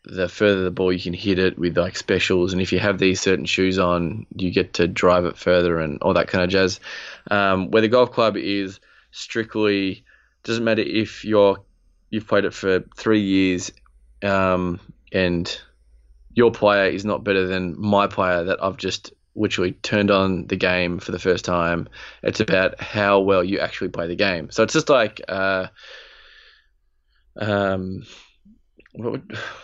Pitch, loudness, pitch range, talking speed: 95 Hz, -21 LUFS, 90-100 Hz, 180 wpm